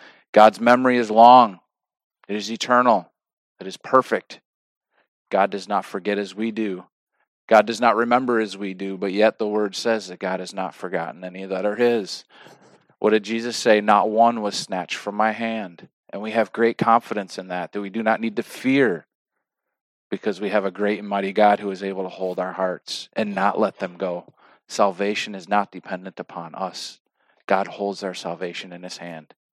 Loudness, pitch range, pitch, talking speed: -21 LUFS, 95-115 Hz, 105 Hz, 195 wpm